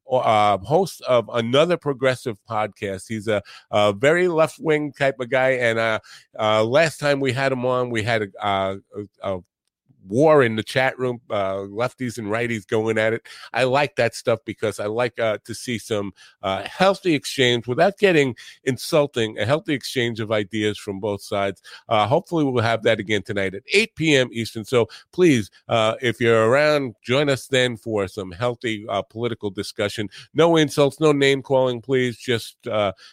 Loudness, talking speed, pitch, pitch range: -21 LUFS, 185 wpm, 120 Hz, 105-135 Hz